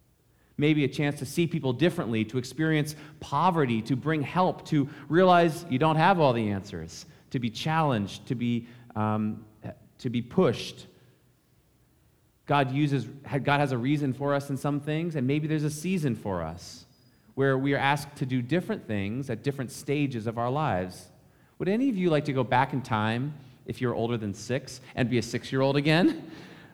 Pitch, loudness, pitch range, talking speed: 135 Hz, -27 LUFS, 120-150 Hz, 190 wpm